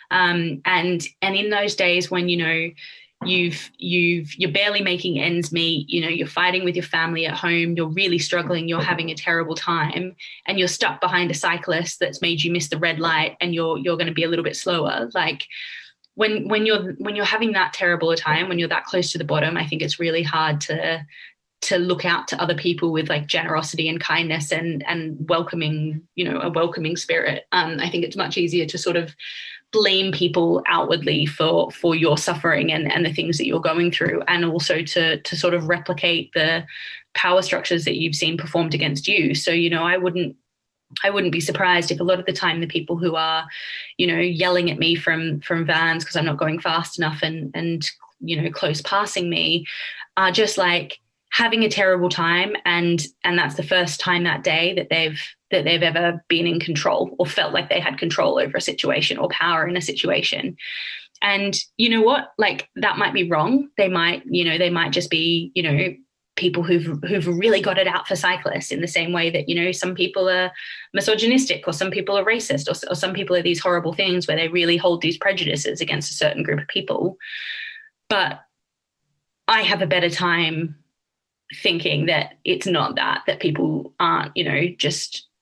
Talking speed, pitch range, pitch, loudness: 210 wpm, 165-180 Hz, 170 Hz, -20 LUFS